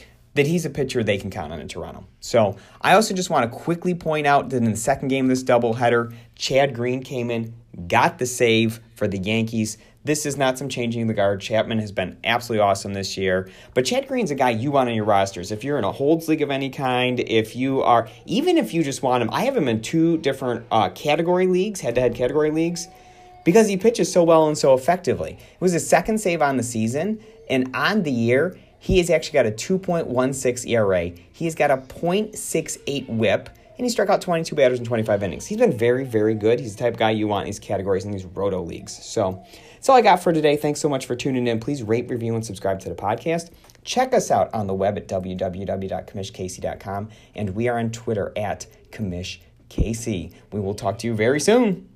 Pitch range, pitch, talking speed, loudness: 110-155 Hz, 125 Hz, 225 wpm, -22 LUFS